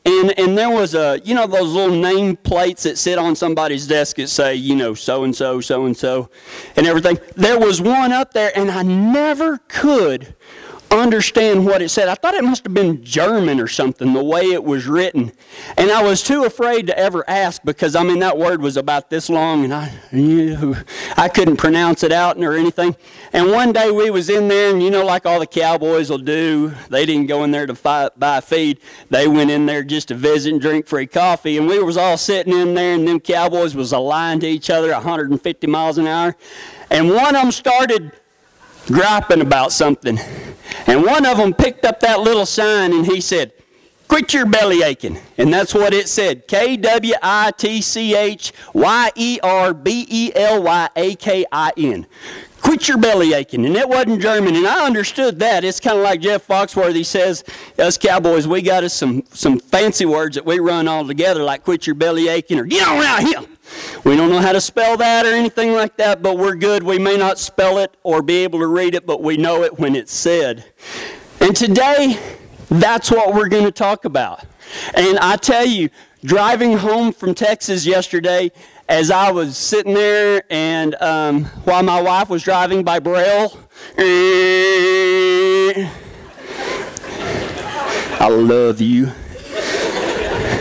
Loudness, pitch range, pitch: -15 LUFS, 160-215 Hz, 185 Hz